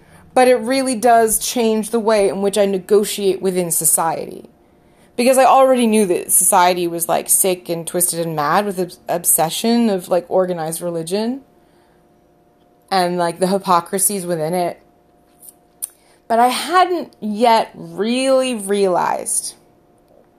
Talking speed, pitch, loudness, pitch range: 130 wpm, 200 Hz, -16 LUFS, 175-230 Hz